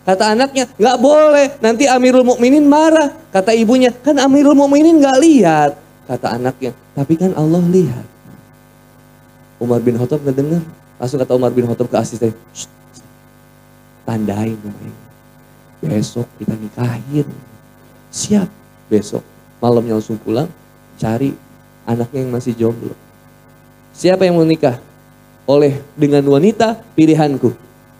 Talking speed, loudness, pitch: 120 wpm, -13 LUFS, 140 Hz